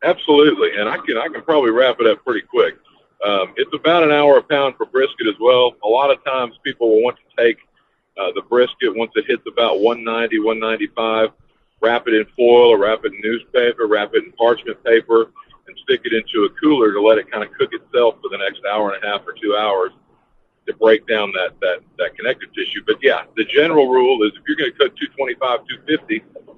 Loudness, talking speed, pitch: -17 LUFS, 225 wpm, 400 Hz